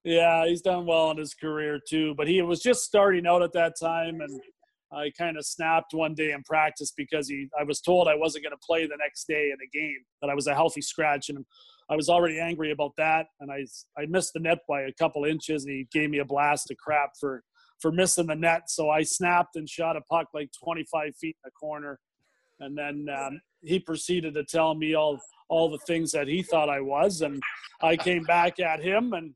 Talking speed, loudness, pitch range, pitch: 235 wpm, -27 LUFS, 145-170 Hz, 155 Hz